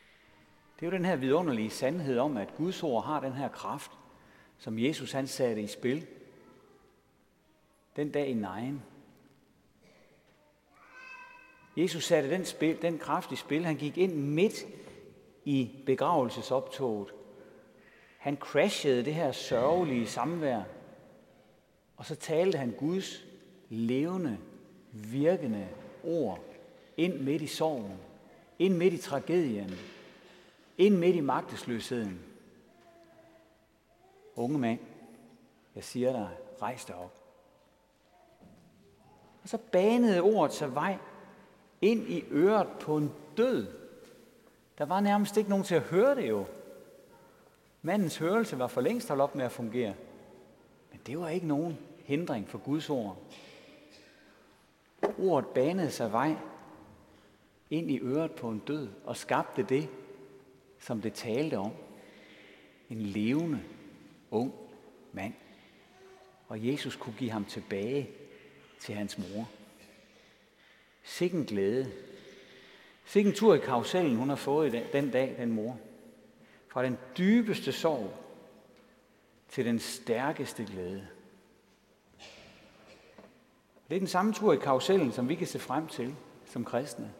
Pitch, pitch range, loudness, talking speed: 145 Hz, 120-180 Hz, -31 LUFS, 125 wpm